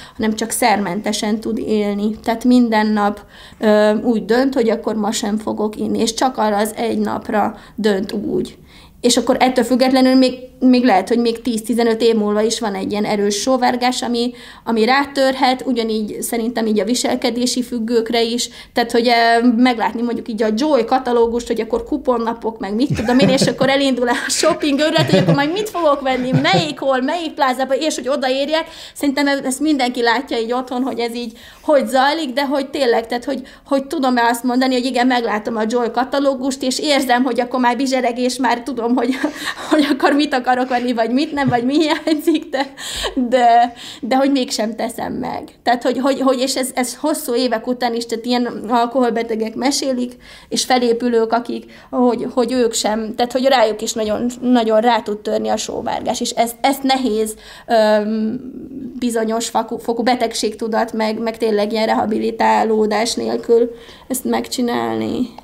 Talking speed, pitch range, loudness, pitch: 175 wpm, 225-260 Hz, -17 LUFS, 245 Hz